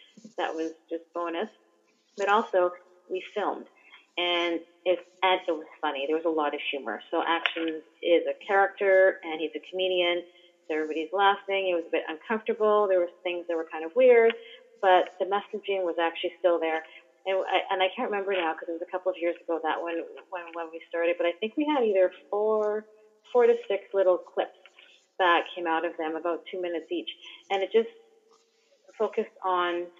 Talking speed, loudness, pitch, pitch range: 200 wpm, -27 LUFS, 180 Hz, 165-200 Hz